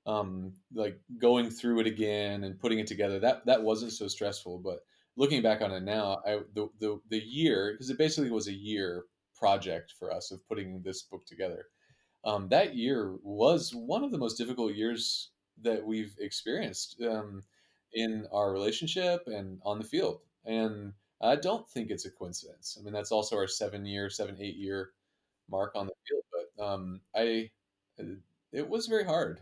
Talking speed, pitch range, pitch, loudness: 180 wpm, 100-120 Hz, 110 Hz, -33 LUFS